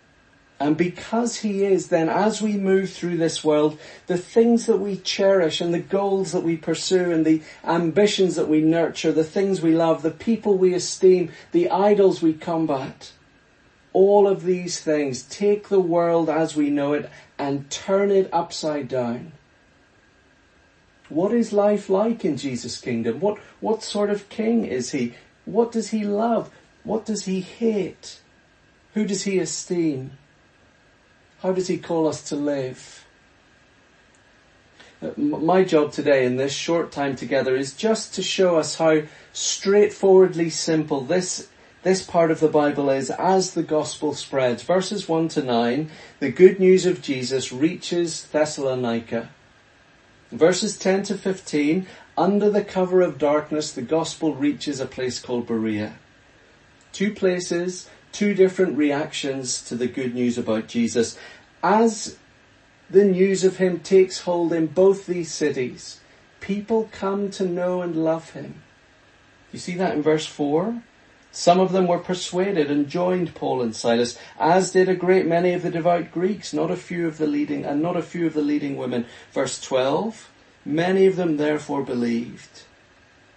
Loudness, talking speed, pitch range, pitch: -22 LUFS, 155 wpm, 145-190 Hz, 170 Hz